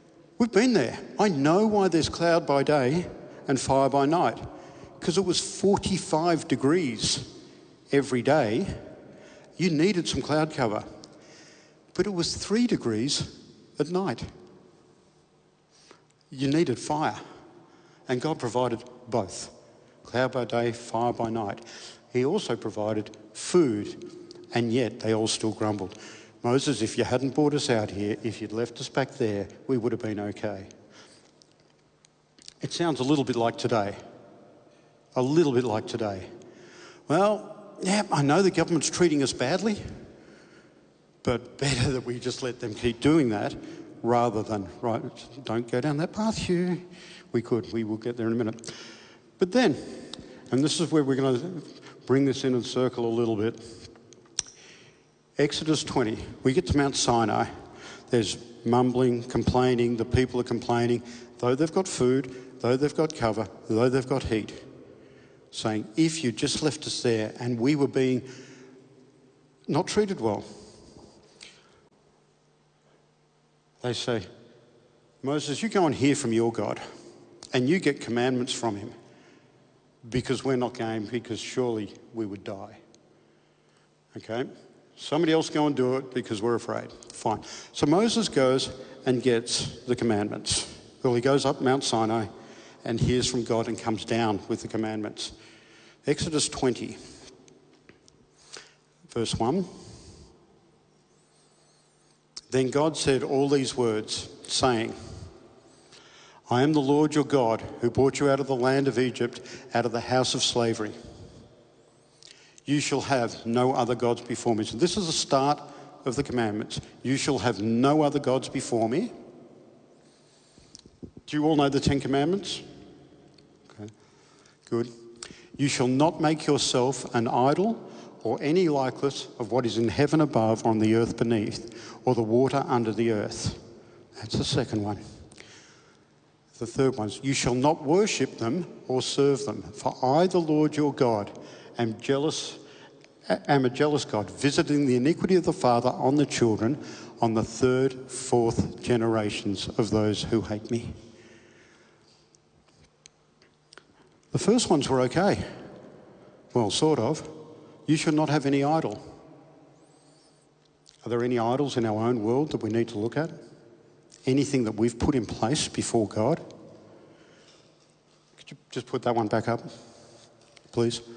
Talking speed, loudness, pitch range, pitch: 150 wpm, -26 LUFS, 115-145 Hz, 125 Hz